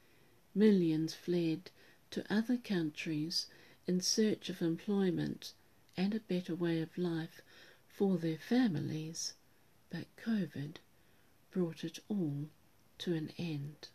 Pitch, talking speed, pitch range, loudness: 170 Hz, 110 wpm, 160-190 Hz, -36 LUFS